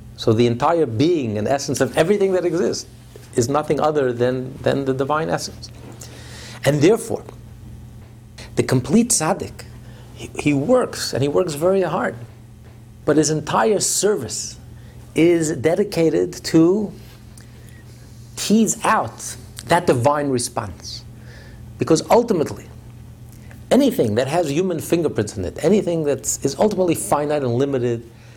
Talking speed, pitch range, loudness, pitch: 125 wpm, 115-160 Hz, -19 LUFS, 125 Hz